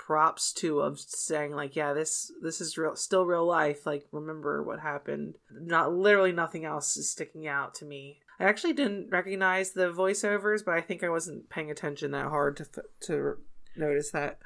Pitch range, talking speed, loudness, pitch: 150-185 Hz, 185 wpm, -29 LUFS, 160 Hz